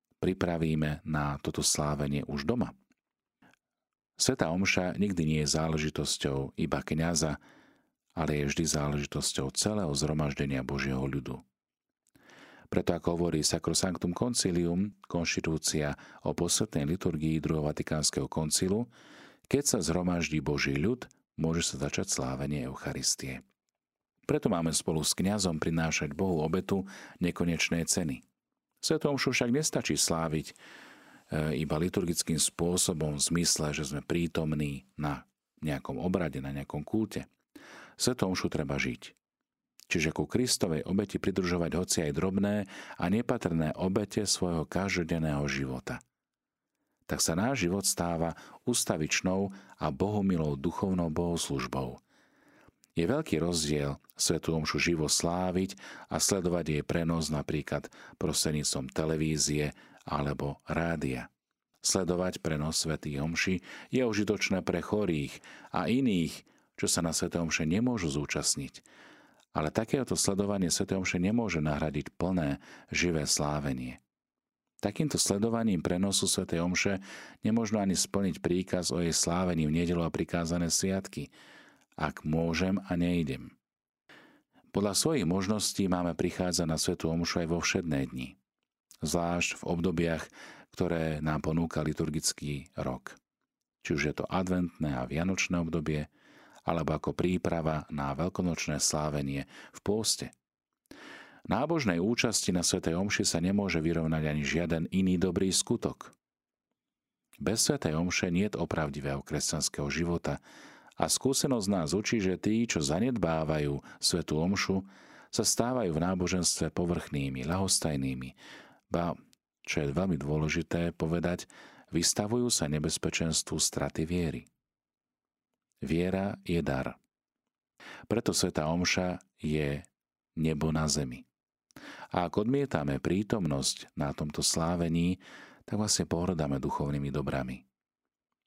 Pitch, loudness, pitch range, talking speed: 80 Hz, -31 LUFS, 75-90 Hz, 115 wpm